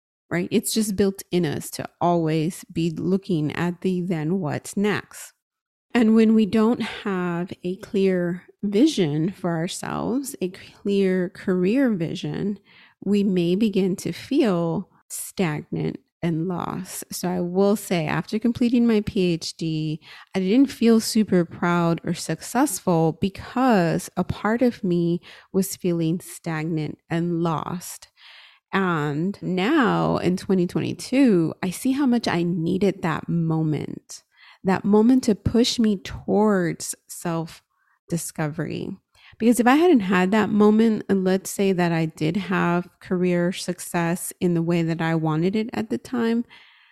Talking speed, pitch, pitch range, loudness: 140 wpm, 185 Hz, 170-210 Hz, -23 LUFS